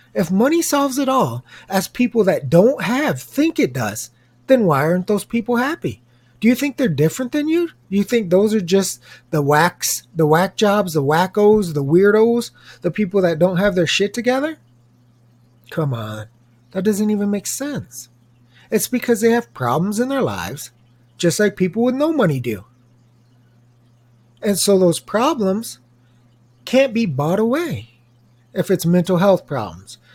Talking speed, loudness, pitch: 165 wpm, -18 LUFS, 180 Hz